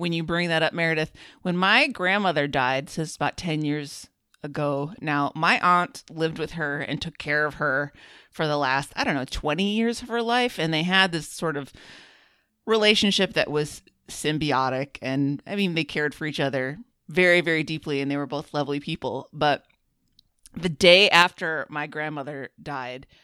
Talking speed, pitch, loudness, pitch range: 185 wpm, 155 Hz, -23 LUFS, 145-175 Hz